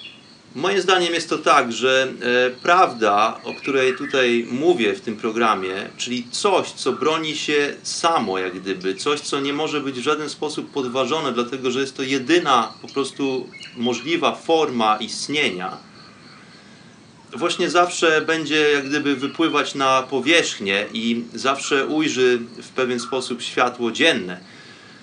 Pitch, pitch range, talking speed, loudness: 135 Hz, 125-155 Hz, 140 wpm, -20 LUFS